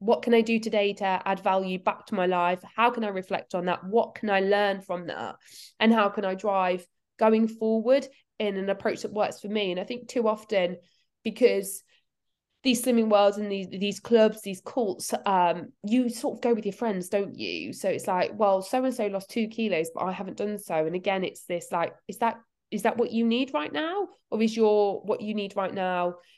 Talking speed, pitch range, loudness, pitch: 230 wpm, 190-230 Hz, -27 LUFS, 205 Hz